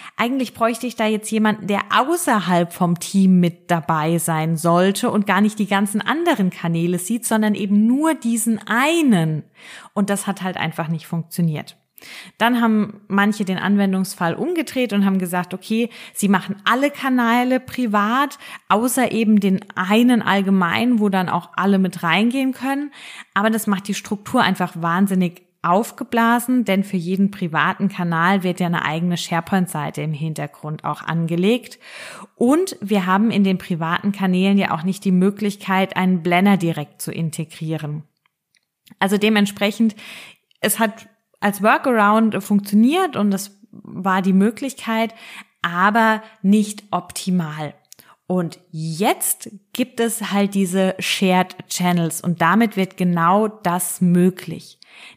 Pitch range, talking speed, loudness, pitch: 180-225 Hz, 140 wpm, -19 LUFS, 200 Hz